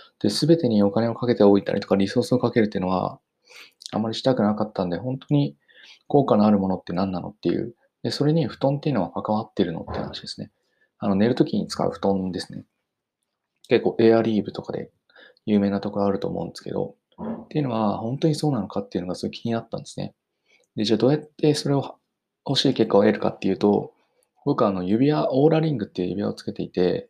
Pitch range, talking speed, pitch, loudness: 100-135 Hz, 460 characters per minute, 115 Hz, -23 LUFS